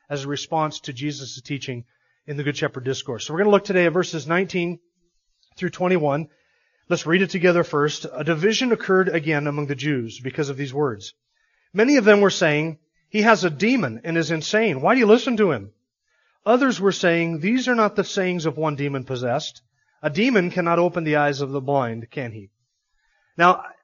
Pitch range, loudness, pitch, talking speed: 145-190 Hz, -21 LUFS, 160 Hz, 200 wpm